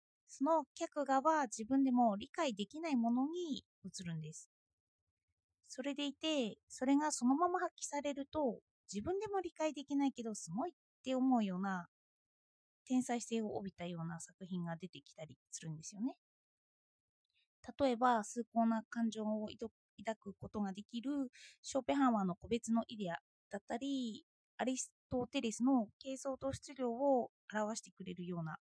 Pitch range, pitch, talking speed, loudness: 195-275 Hz, 235 Hz, 305 characters per minute, -39 LUFS